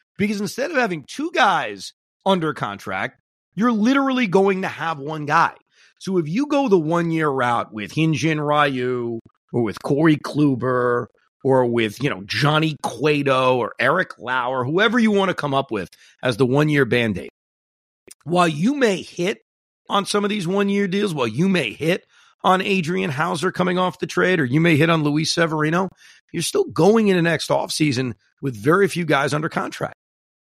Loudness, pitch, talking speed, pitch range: -20 LUFS, 165 Hz, 180 wpm, 135-195 Hz